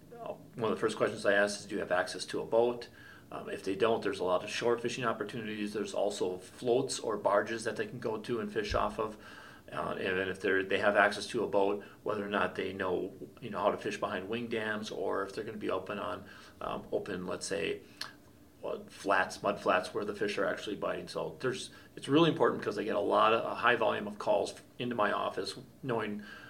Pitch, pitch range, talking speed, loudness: 110 Hz, 105-120 Hz, 240 wpm, -33 LUFS